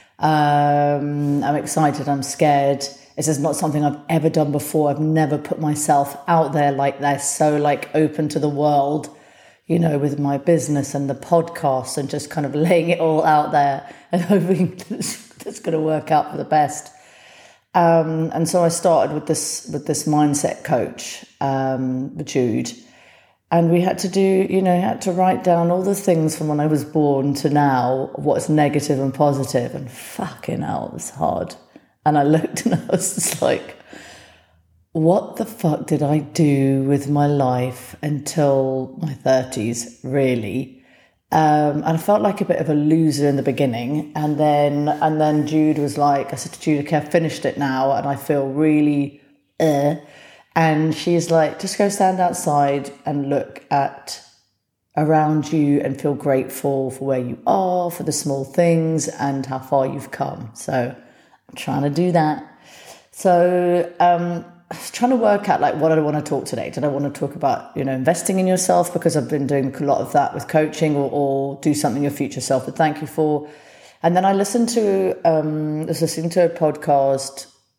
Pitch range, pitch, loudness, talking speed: 140-165 Hz, 150 Hz, -19 LUFS, 190 wpm